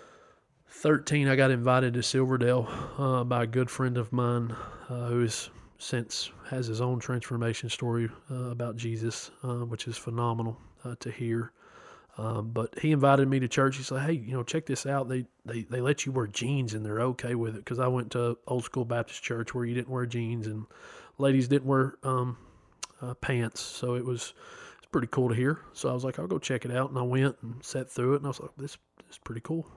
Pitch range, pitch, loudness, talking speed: 120-135 Hz, 125 Hz, -30 LUFS, 225 wpm